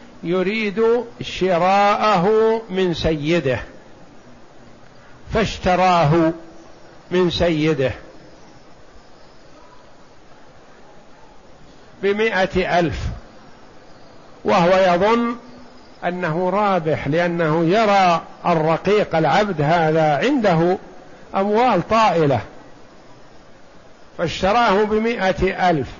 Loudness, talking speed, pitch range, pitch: -18 LUFS, 55 wpm, 165-205 Hz, 180 Hz